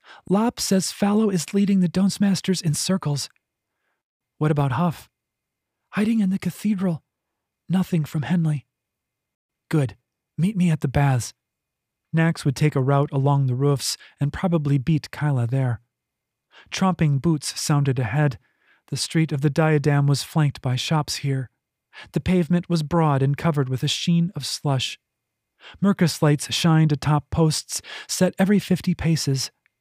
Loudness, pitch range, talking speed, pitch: -22 LUFS, 140-175 Hz, 145 wpm, 155 Hz